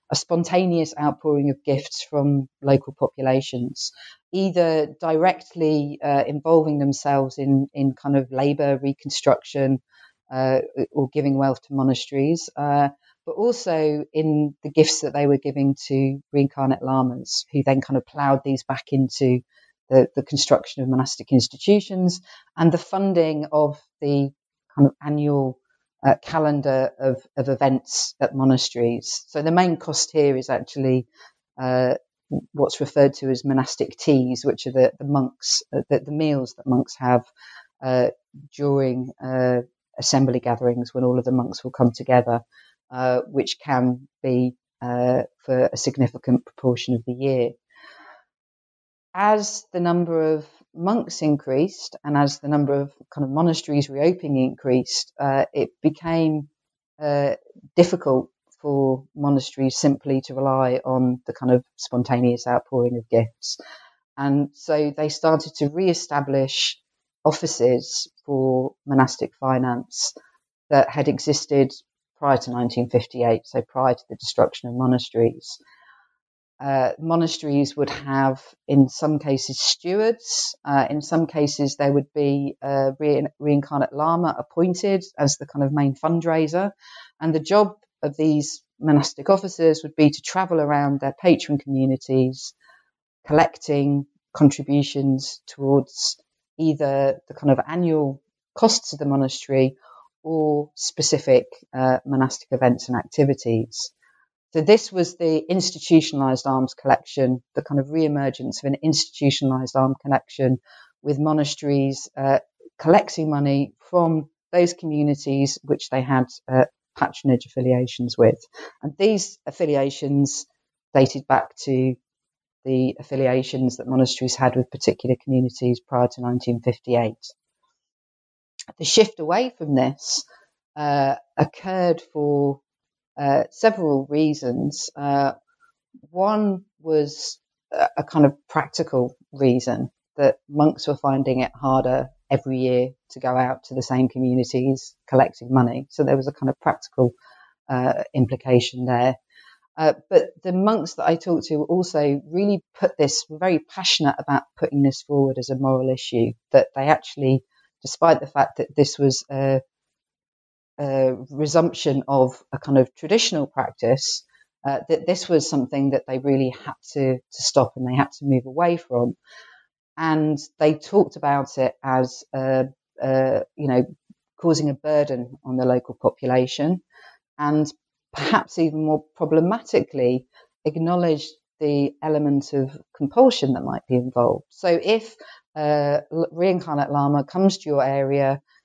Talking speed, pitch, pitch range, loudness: 135 wpm, 140 Hz, 130-155 Hz, -22 LUFS